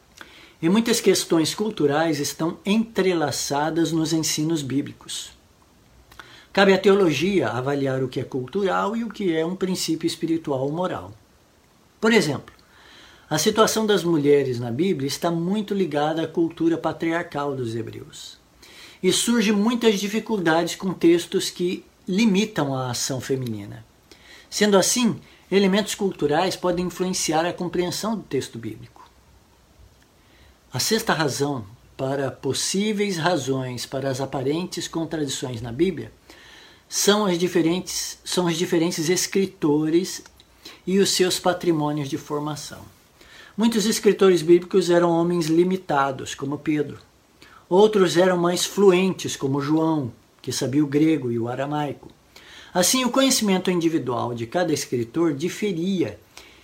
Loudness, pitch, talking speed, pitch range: -22 LUFS, 170 Hz, 125 wpm, 145-185 Hz